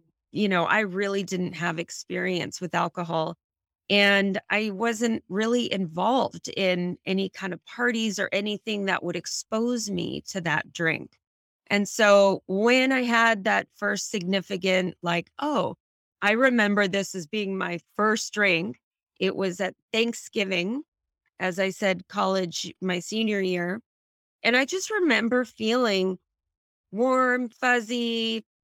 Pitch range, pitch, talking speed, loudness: 185-225 Hz, 200 Hz, 135 wpm, -25 LUFS